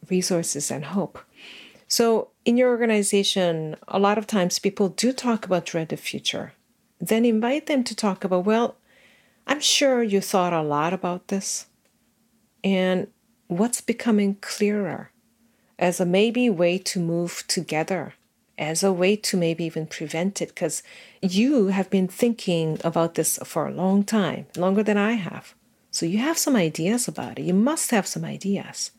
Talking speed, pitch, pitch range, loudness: 165 wpm, 195 Hz, 175-225 Hz, -23 LUFS